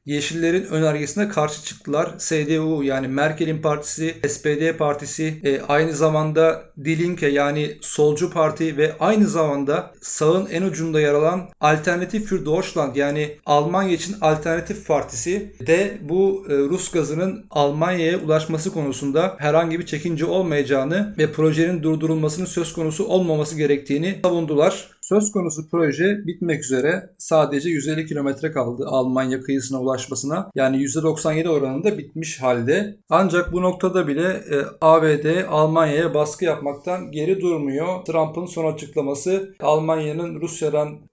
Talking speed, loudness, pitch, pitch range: 125 wpm, -21 LUFS, 160 Hz, 150-175 Hz